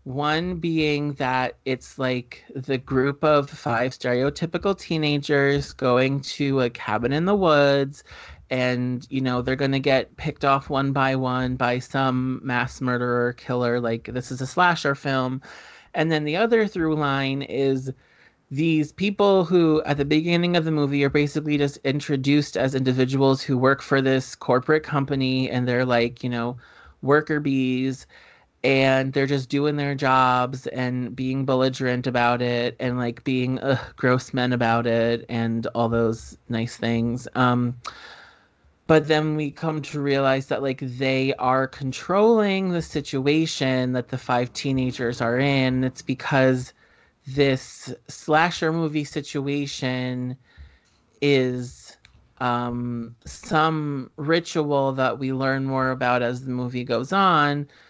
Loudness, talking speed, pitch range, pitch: -23 LUFS, 145 wpm, 125-145 Hz, 135 Hz